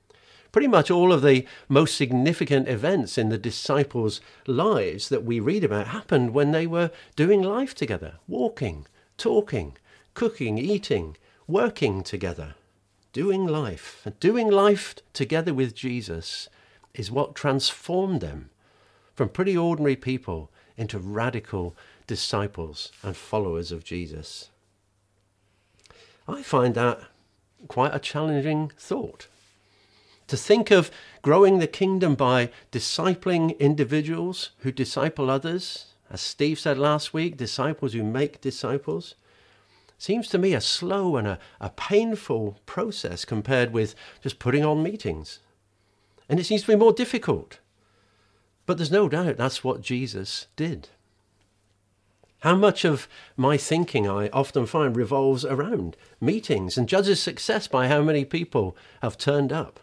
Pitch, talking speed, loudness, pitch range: 135 Hz, 130 wpm, -24 LUFS, 105-170 Hz